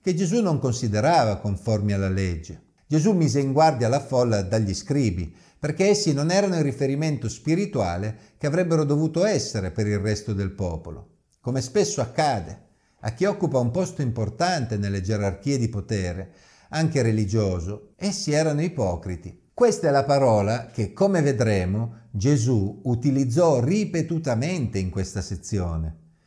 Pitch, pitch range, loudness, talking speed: 120 Hz, 100-155 Hz, -24 LUFS, 140 wpm